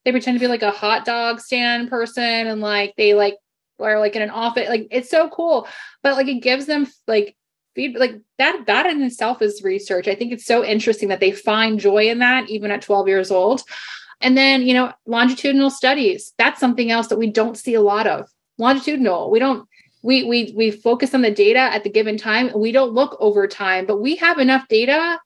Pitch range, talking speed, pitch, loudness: 215-260 Hz, 220 wpm, 235 Hz, -18 LUFS